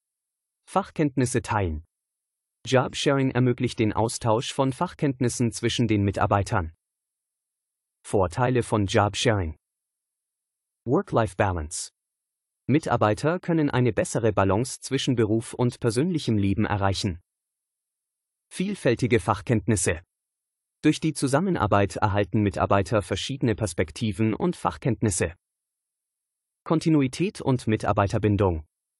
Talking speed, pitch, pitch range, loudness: 85 wpm, 115 Hz, 100-135 Hz, -25 LUFS